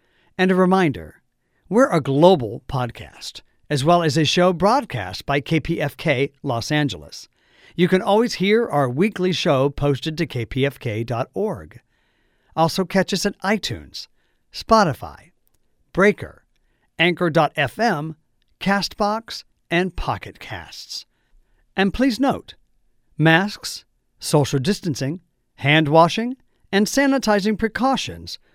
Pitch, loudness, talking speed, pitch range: 165 Hz, -20 LUFS, 105 wpm, 140-200 Hz